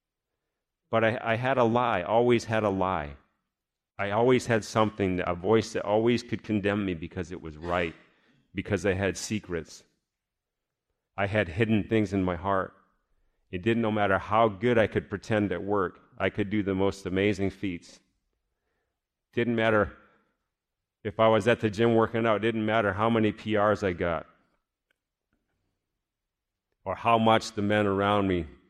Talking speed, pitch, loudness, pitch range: 165 wpm, 105 Hz, -27 LUFS, 95-115 Hz